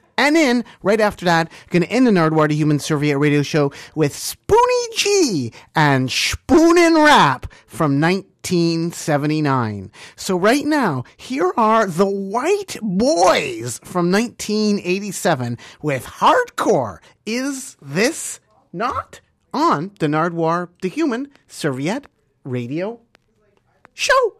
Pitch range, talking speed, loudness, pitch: 155-255 Hz, 110 wpm, -18 LUFS, 185 Hz